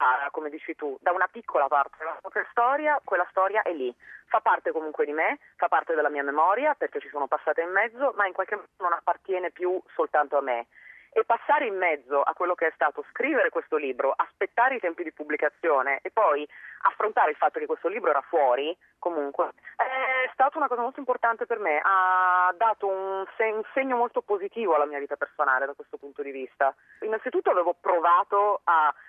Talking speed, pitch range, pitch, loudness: 195 wpm, 155-240 Hz, 190 Hz, -26 LUFS